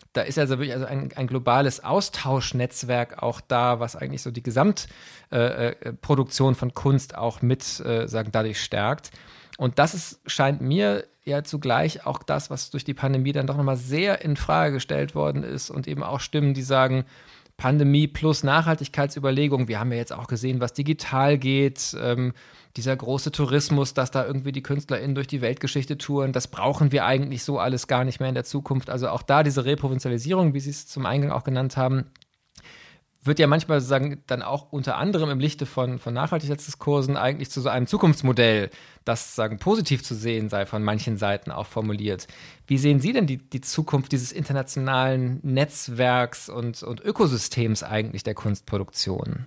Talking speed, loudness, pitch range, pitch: 180 wpm, -24 LUFS, 125-145 Hz, 135 Hz